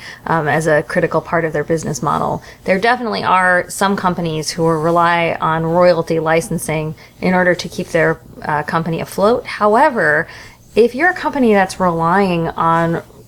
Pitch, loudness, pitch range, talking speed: 170 Hz, -15 LUFS, 165-190 Hz, 160 wpm